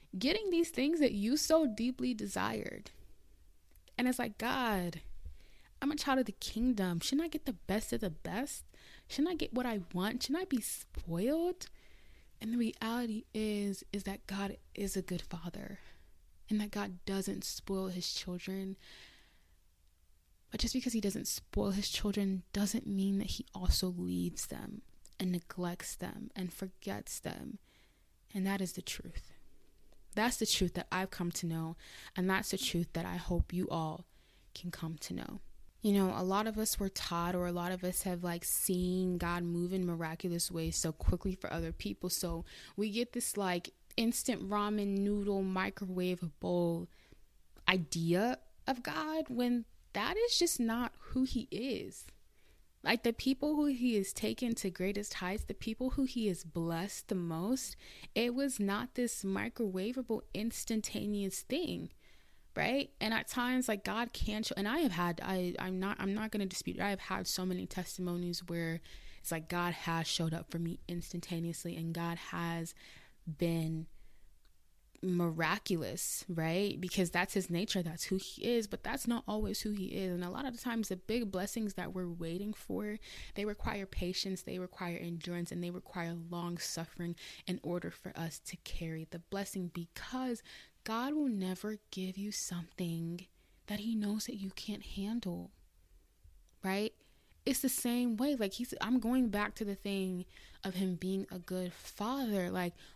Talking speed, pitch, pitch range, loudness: 175 wpm, 190 Hz, 175-225 Hz, -37 LUFS